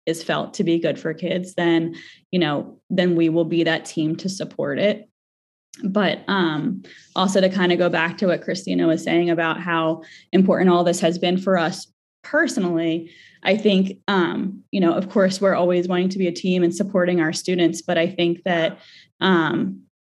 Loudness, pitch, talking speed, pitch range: -21 LUFS, 175 Hz, 195 wpm, 165-190 Hz